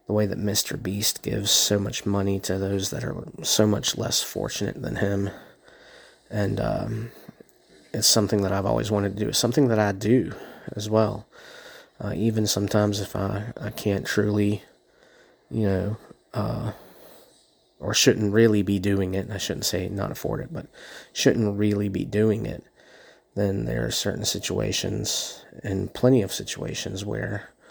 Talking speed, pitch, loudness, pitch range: 165 wpm, 105 Hz, -24 LUFS, 100-110 Hz